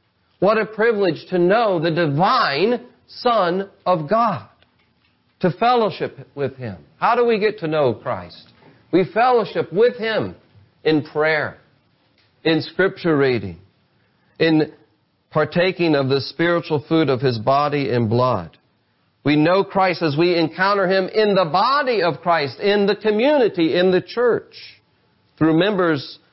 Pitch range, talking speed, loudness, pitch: 140-195 Hz, 140 wpm, -19 LUFS, 165 Hz